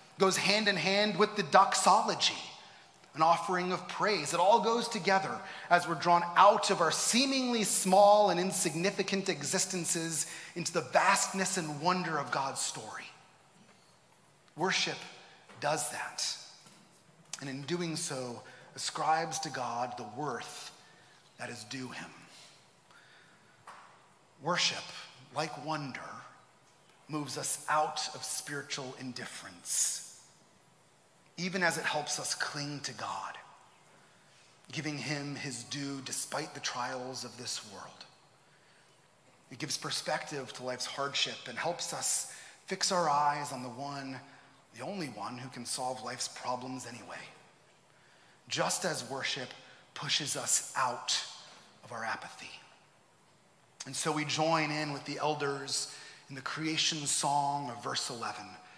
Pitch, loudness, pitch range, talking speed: 150 Hz, -32 LUFS, 135-180 Hz, 130 wpm